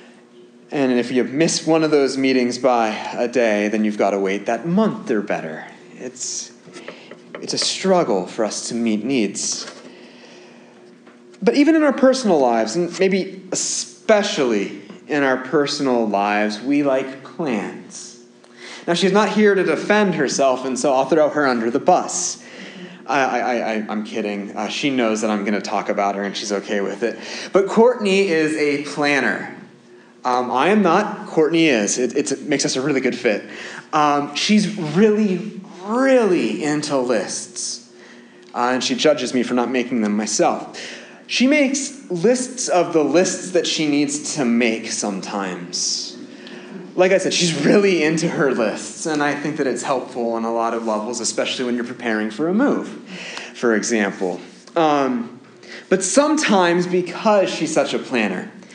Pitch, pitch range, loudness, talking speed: 145 Hz, 120-185 Hz, -19 LUFS, 170 wpm